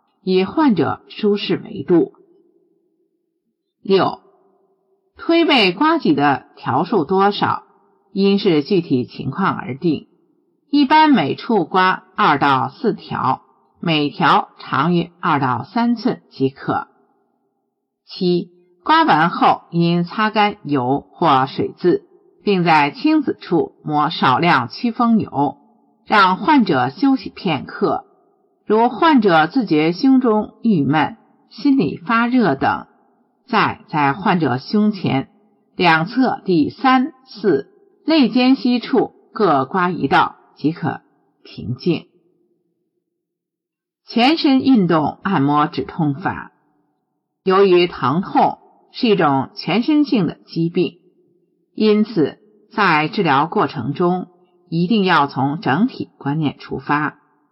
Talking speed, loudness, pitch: 155 characters per minute, -17 LUFS, 205 Hz